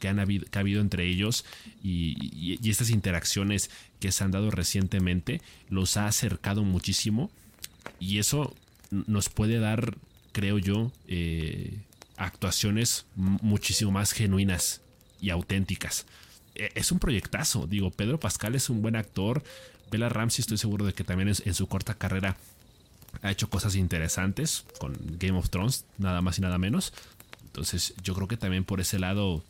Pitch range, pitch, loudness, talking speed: 95-110 Hz, 100 Hz, -29 LUFS, 160 wpm